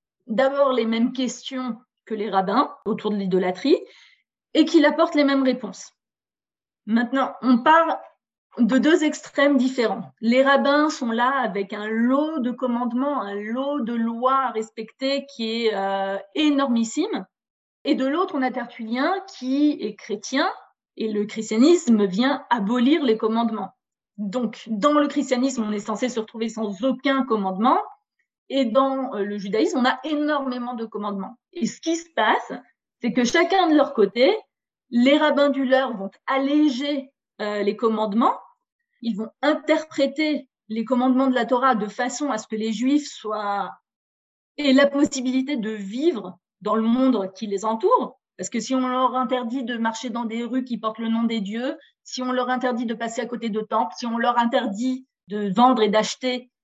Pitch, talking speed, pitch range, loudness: 250 Hz, 170 wpm, 220-275 Hz, -22 LUFS